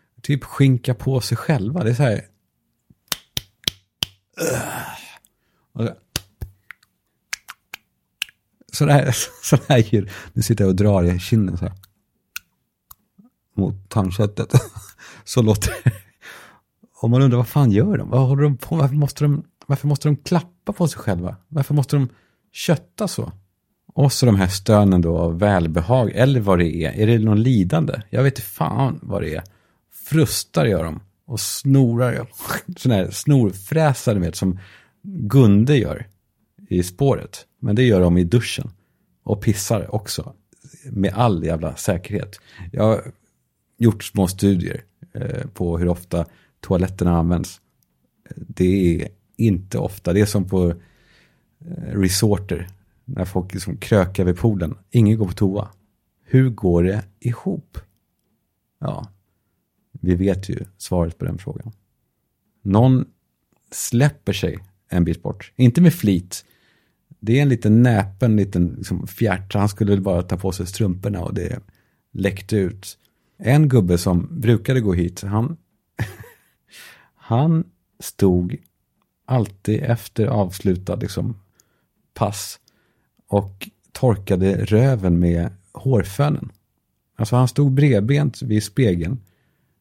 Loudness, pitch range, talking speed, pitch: -20 LUFS, 95-125 Hz, 130 wpm, 105 Hz